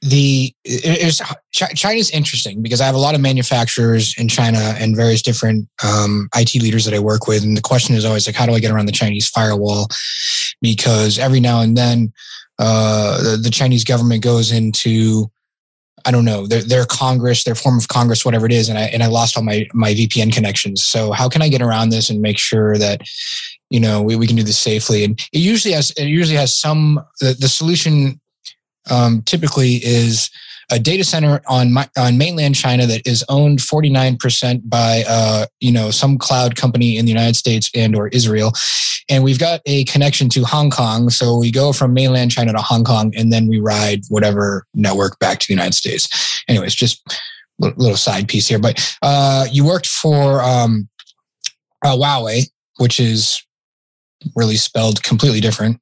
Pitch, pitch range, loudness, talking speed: 120 Hz, 110-135 Hz, -14 LUFS, 195 wpm